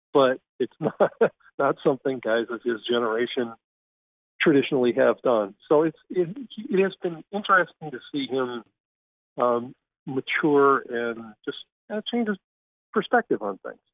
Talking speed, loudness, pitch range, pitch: 140 wpm, -25 LUFS, 115-170 Hz, 130 Hz